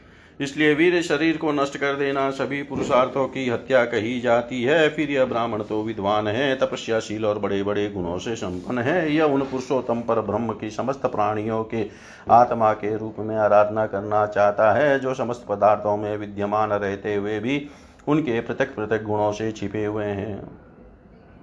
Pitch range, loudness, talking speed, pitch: 105-135 Hz, -22 LUFS, 170 wpm, 110 Hz